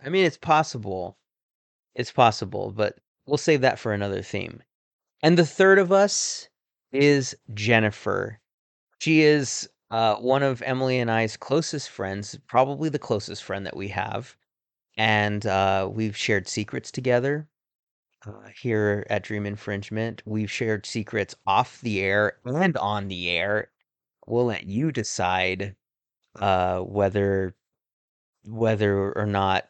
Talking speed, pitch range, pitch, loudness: 135 wpm, 100-135 Hz, 110 Hz, -24 LUFS